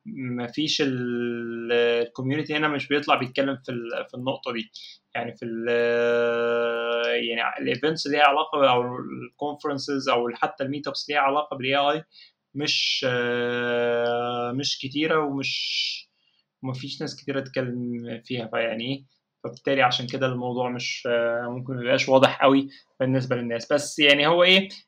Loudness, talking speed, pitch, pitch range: -24 LUFS, 140 wpm, 130 Hz, 120-145 Hz